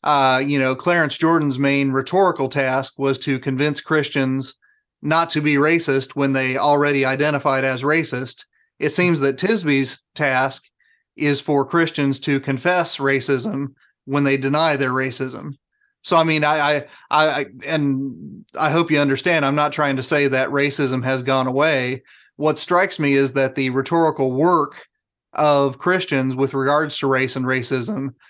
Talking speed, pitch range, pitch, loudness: 160 wpm, 135-155 Hz, 140 Hz, -19 LUFS